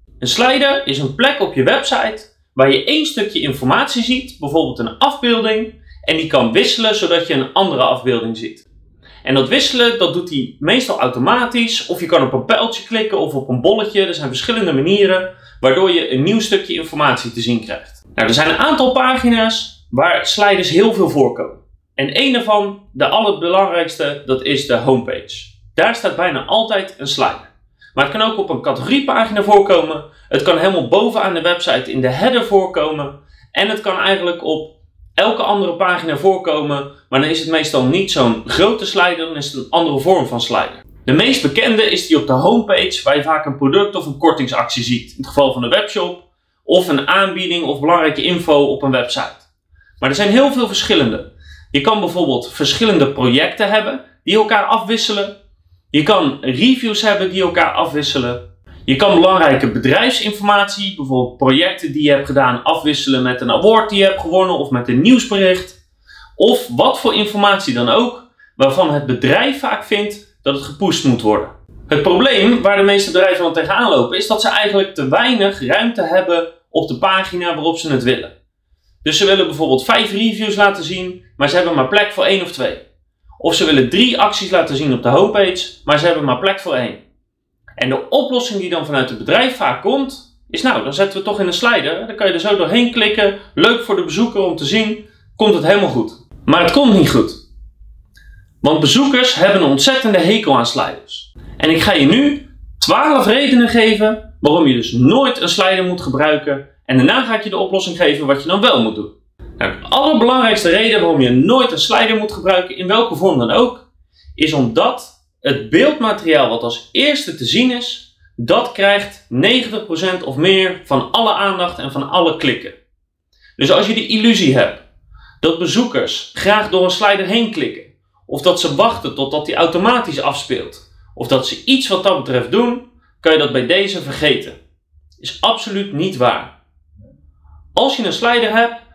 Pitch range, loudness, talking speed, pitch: 140-220 Hz, -14 LUFS, 190 wpm, 185 Hz